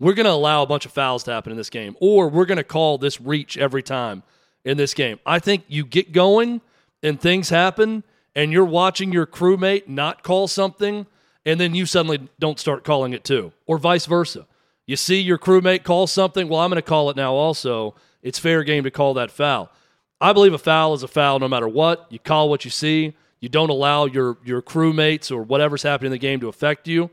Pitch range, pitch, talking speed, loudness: 140-180 Hz, 155 Hz, 230 wpm, -19 LUFS